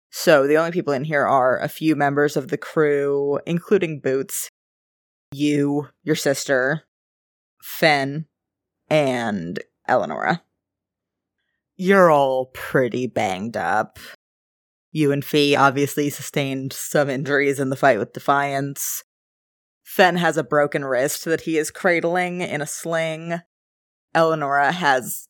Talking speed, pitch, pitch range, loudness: 125 wpm, 145 Hz, 135-160 Hz, -20 LUFS